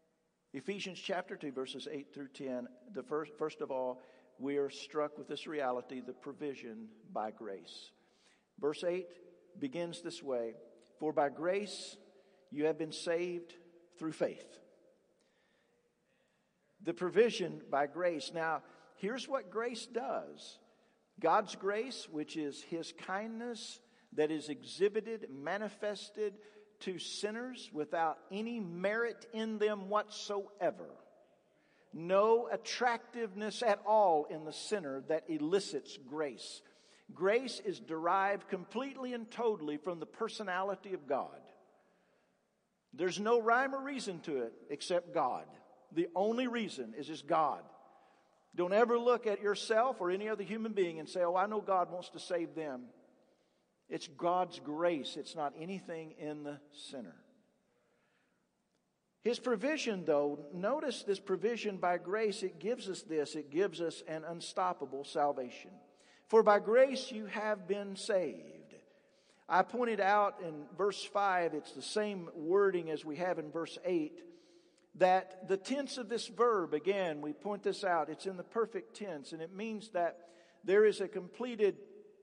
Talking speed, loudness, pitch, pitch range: 140 wpm, -36 LUFS, 185 Hz, 160-215 Hz